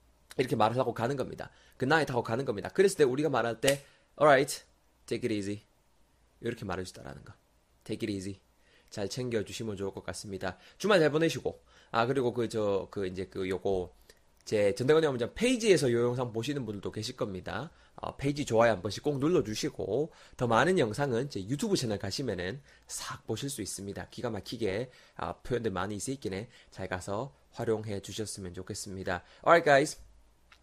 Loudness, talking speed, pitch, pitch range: -31 LUFS, 425 characters per minute, 110 Hz, 95-130 Hz